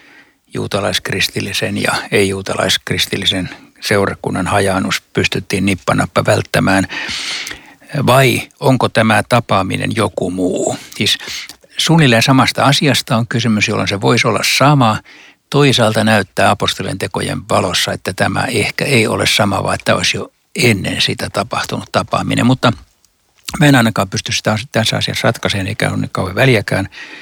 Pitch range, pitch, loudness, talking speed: 100-130 Hz, 110 Hz, -14 LUFS, 130 wpm